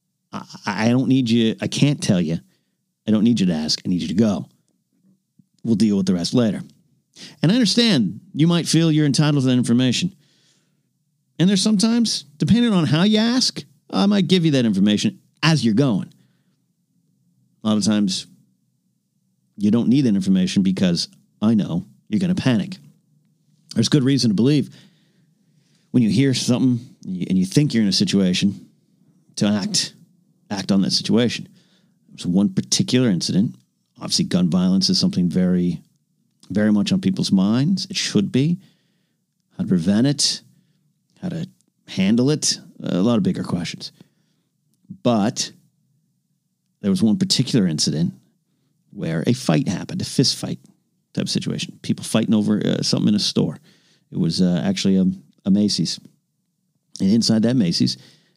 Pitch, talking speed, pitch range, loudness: 180 Hz, 160 wpm, 150-195 Hz, -19 LUFS